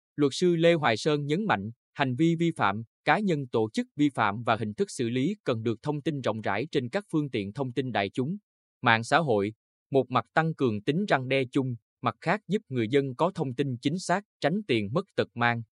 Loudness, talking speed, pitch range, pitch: -28 LUFS, 235 wpm, 115-160 Hz, 135 Hz